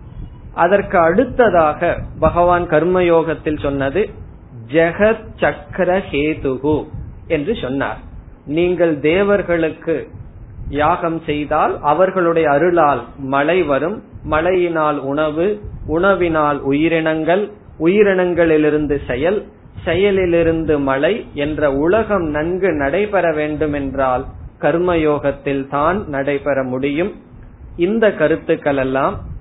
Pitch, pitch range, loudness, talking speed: 155 Hz, 145-175 Hz, -16 LUFS, 80 wpm